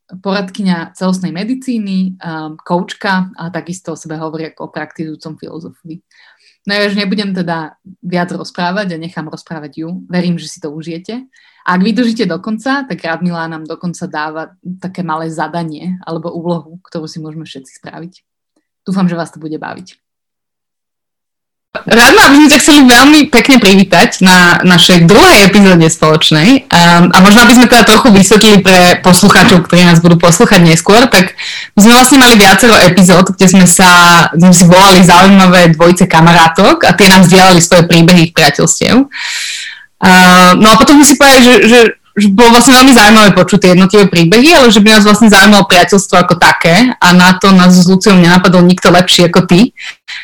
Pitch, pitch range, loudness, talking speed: 180 Hz, 170-210 Hz, -4 LUFS, 170 wpm